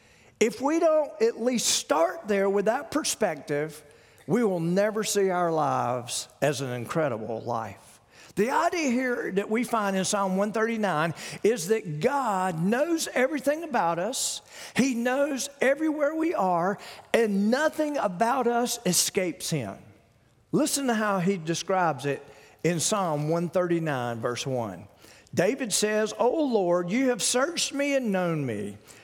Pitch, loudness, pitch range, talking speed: 200 Hz, -26 LUFS, 150-250 Hz, 145 wpm